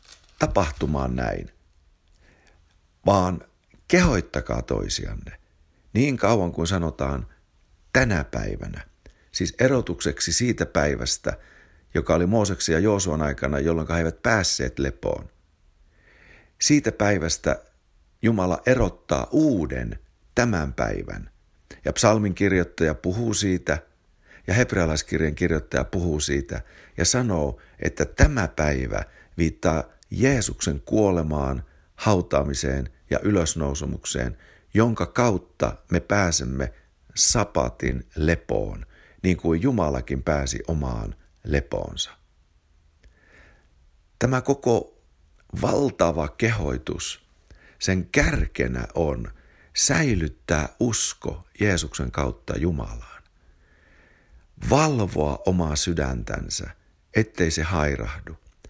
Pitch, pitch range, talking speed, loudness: 80 Hz, 70-95 Hz, 85 wpm, -24 LUFS